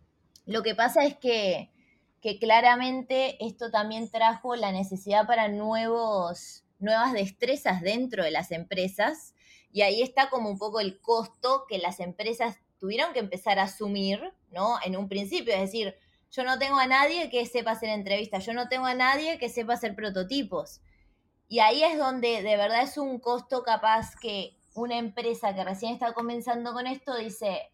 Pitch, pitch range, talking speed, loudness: 225 Hz, 200-245 Hz, 175 wpm, -27 LUFS